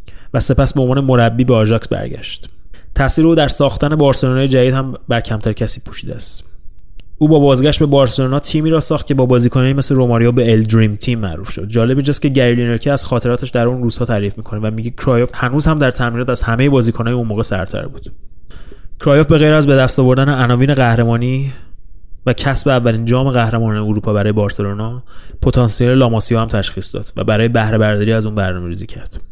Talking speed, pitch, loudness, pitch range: 190 wpm, 120 Hz, -13 LUFS, 110-135 Hz